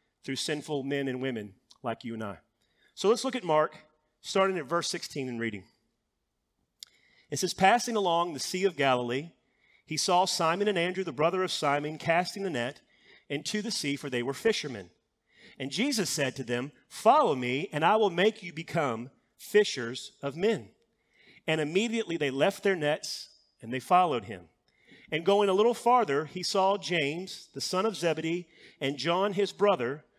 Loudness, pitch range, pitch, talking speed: -29 LUFS, 140-195 Hz, 165 Hz, 175 wpm